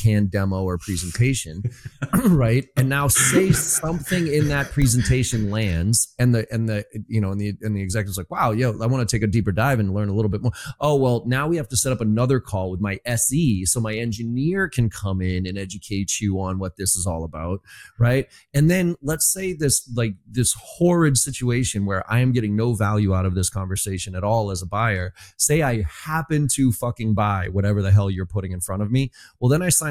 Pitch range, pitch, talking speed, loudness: 100-130 Hz, 115 Hz, 225 wpm, -21 LUFS